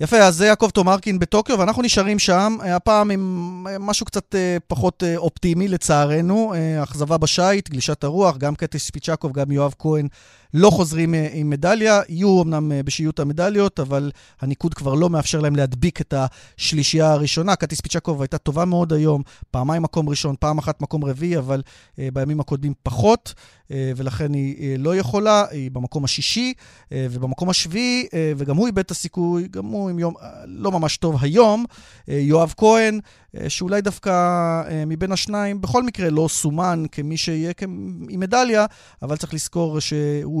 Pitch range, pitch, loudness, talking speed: 145-190 Hz, 165 Hz, -20 LUFS, 150 wpm